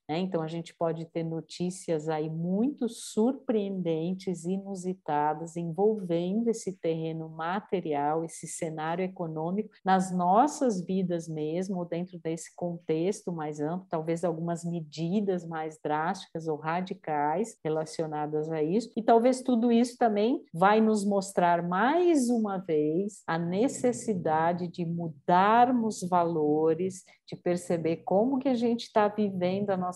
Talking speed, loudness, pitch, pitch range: 125 wpm, -29 LUFS, 180 Hz, 165-210 Hz